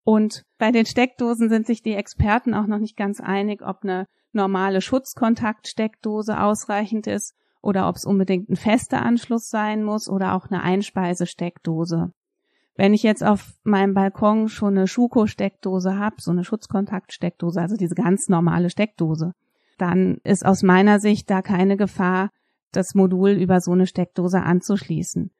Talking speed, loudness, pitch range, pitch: 155 wpm, -21 LUFS, 185-215 Hz, 200 Hz